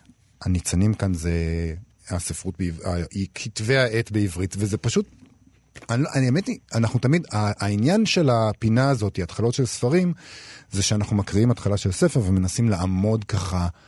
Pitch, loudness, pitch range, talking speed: 110 Hz, -23 LUFS, 95-125 Hz, 135 wpm